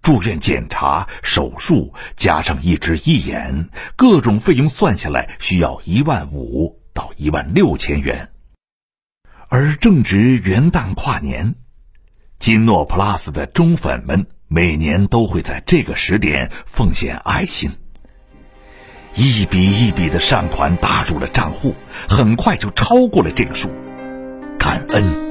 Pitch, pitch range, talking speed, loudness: 100 Hz, 80-125 Hz, 195 characters per minute, -16 LUFS